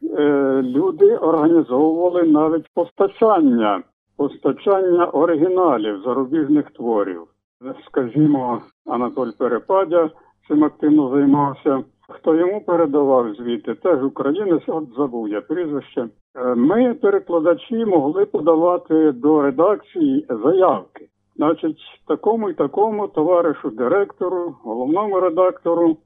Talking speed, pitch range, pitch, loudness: 90 wpm, 140-185 Hz, 160 Hz, -18 LUFS